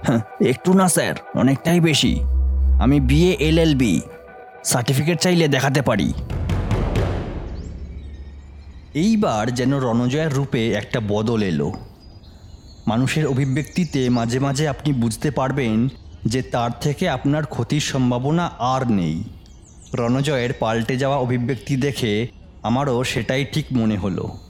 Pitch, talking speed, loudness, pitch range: 125 Hz, 110 wpm, -20 LUFS, 105-140 Hz